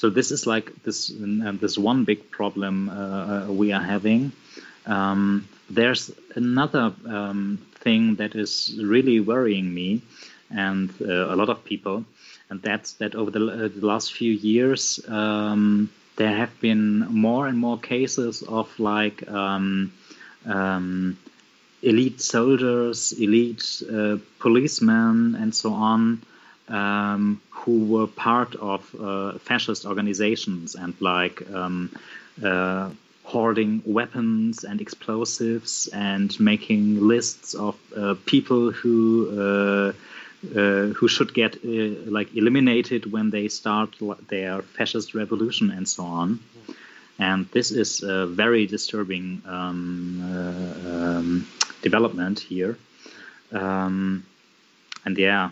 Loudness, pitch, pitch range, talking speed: -23 LUFS, 105 Hz, 100-115 Hz, 125 wpm